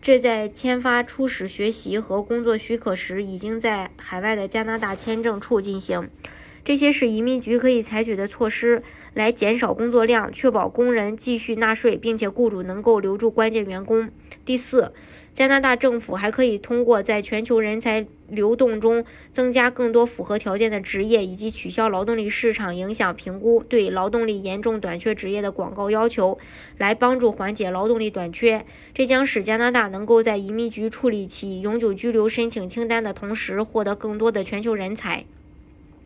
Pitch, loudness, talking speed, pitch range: 225 Hz, -22 LUFS, 285 characters per minute, 205-235 Hz